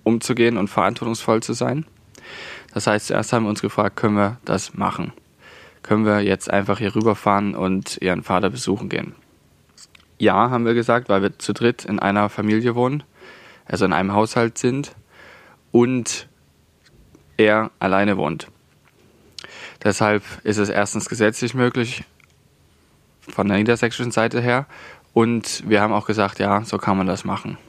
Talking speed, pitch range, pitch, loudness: 150 wpm, 100-115 Hz, 105 Hz, -20 LUFS